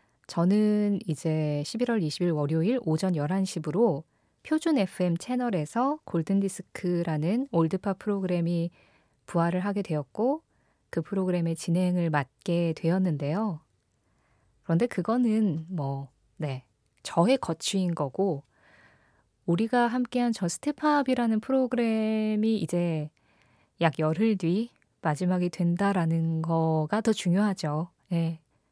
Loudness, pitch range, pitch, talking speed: -28 LUFS, 160-215 Hz, 175 Hz, 245 characters per minute